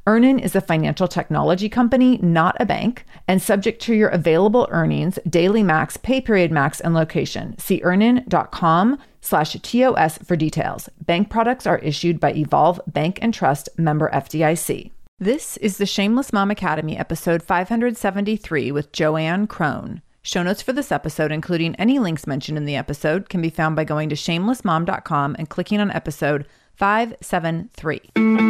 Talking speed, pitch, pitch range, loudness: 155 wpm, 180 Hz, 155-215 Hz, -20 LUFS